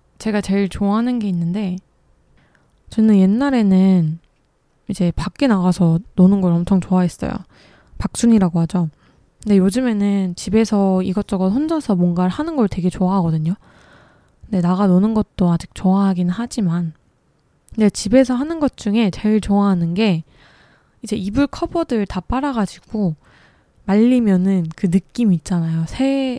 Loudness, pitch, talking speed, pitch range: -18 LUFS, 195 Hz, 300 characters per minute, 180-220 Hz